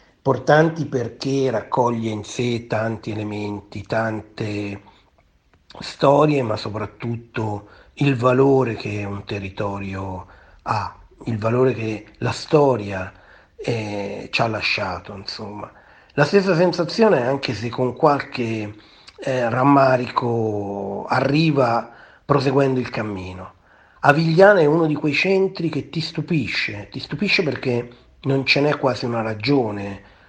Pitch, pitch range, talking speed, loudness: 120 Hz, 105-140 Hz, 115 wpm, -20 LUFS